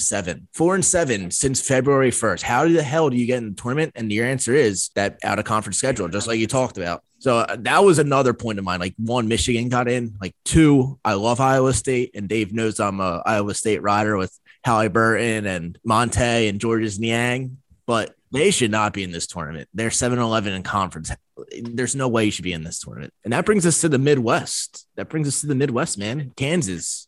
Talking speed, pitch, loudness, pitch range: 225 wpm, 115 Hz, -20 LUFS, 105-135 Hz